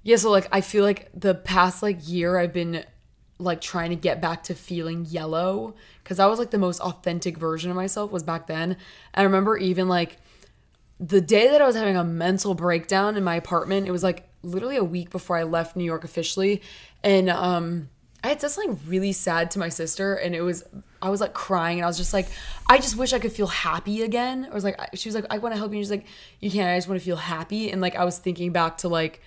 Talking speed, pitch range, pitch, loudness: 250 wpm, 170-200 Hz, 185 Hz, -24 LUFS